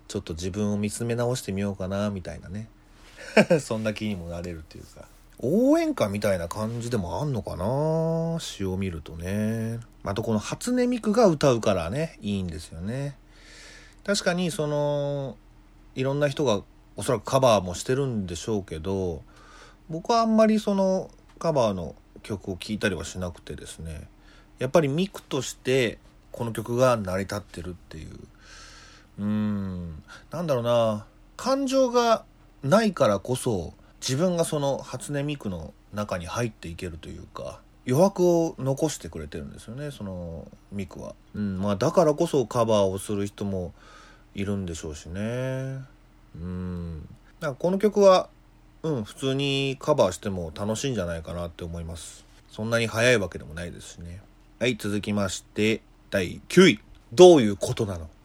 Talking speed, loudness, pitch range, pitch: 320 characters per minute, -25 LUFS, 95-140 Hz, 105 Hz